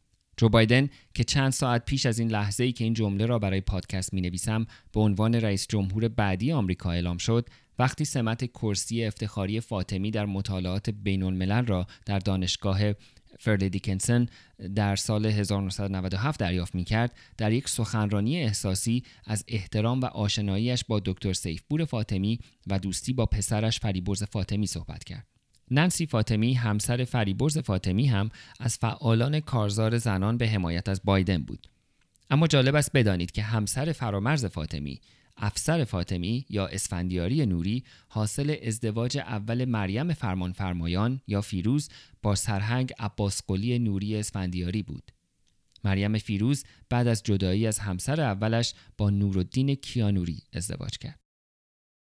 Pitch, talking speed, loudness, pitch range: 105 Hz, 140 wpm, -28 LUFS, 95-120 Hz